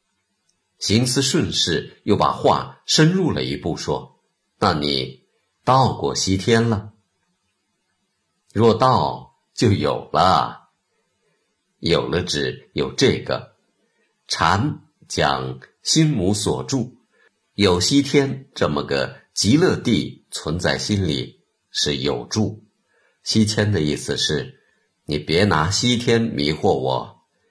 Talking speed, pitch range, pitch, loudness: 145 characters per minute, 75-120 Hz, 105 Hz, -20 LUFS